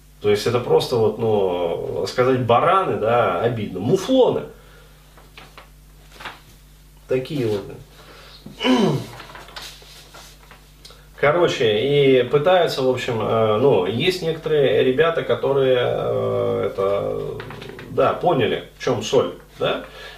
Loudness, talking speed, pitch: -19 LUFS, 90 wpm, 140 Hz